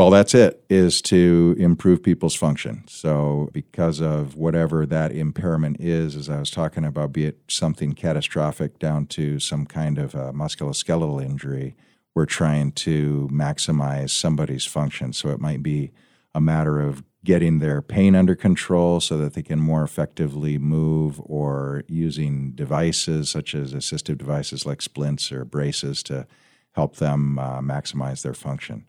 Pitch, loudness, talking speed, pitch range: 75 Hz, -22 LUFS, 155 wpm, 70-80 Hz